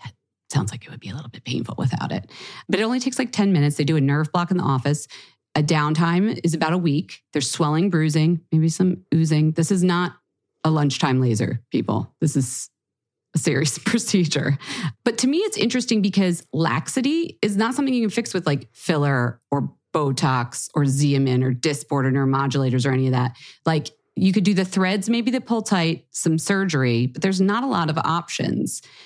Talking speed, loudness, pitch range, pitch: 200 wpm, -22 LUFS, 140-195 Hz, 160 Hz